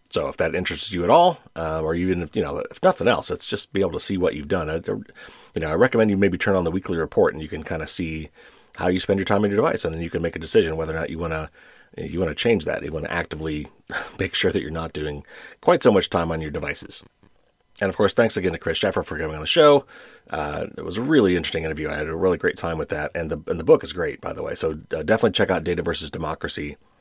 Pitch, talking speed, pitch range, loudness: 85 Hz, 295 wpm, 80-95 Hz, -23 LUFS